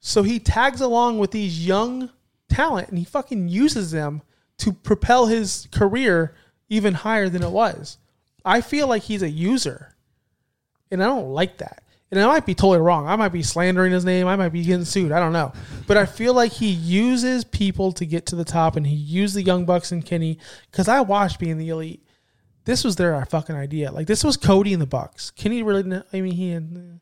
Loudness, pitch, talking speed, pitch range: -21 LUFS, 185 Hz, 215 wpm, 170-215 Hz